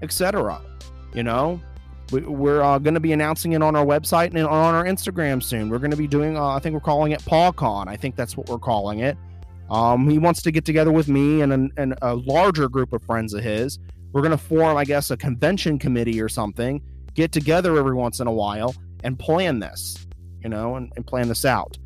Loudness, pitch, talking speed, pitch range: -21 LUFS, 130 Hz, 230 wpm, 110-155 Hz